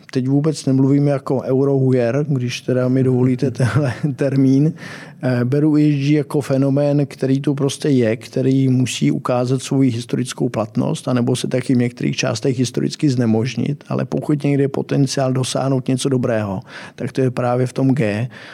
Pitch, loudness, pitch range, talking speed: 130 Hz, -18 LUFS, 125-140 Hz, 155 wpm